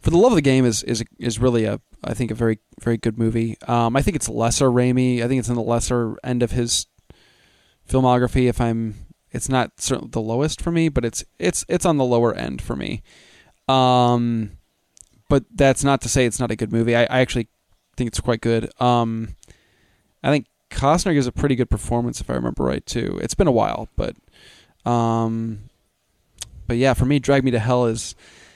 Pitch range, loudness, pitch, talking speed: 115-125 Hz, -20 LUFS, 120 Hz, 210 wpm